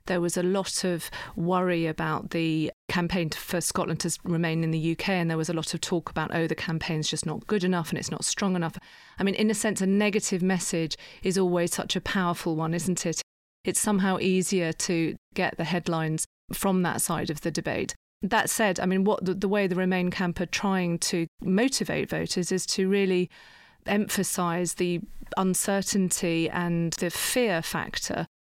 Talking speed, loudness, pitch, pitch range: 190 wpm, -27 LUFS, 180 Hz, 165-190 Hz